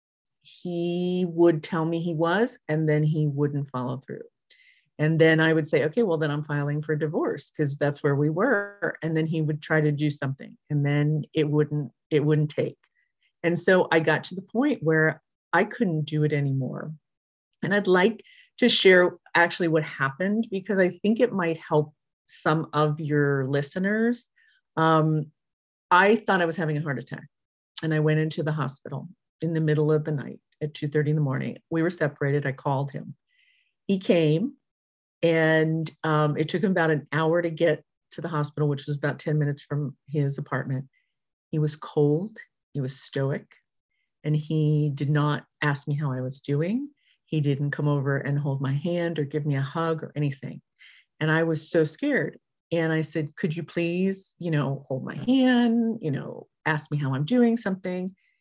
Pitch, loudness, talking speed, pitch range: 155 Hz, -25 LUFS, 190 wpm, 145-175 Hz